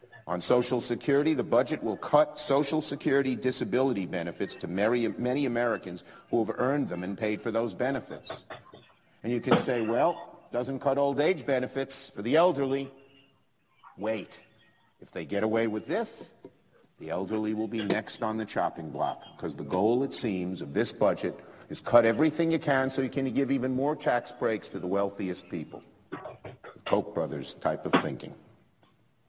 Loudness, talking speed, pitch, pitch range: -29 LUFS, 170 wpm, 125 Hz, 110-135 Hz